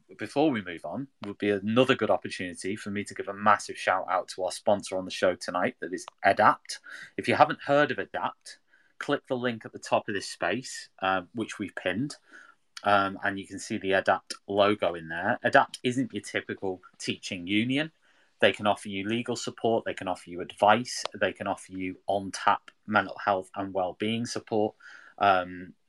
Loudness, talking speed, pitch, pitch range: -28 LUFS, 200 wpm, 100 Hz, 95-115 Hz